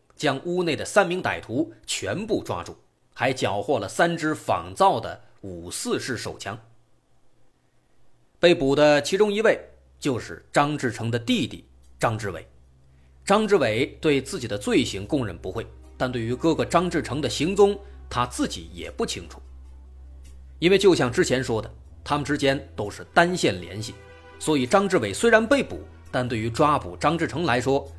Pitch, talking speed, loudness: 125 Hz, 240 characters per minute, -24 LUFS